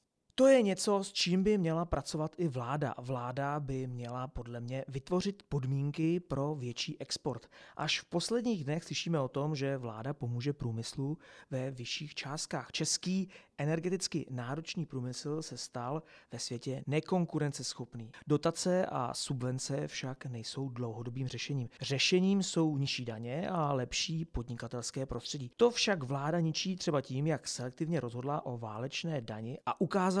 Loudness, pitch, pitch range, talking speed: -35 LUFS, 145 Hz, 125-165 Hz, 145 wpm